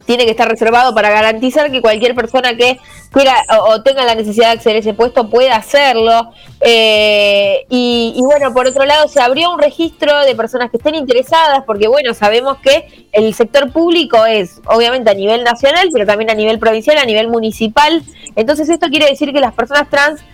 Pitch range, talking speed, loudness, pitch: 225-290 Hz, 195 wpm, -11 LUFS, 245 Hz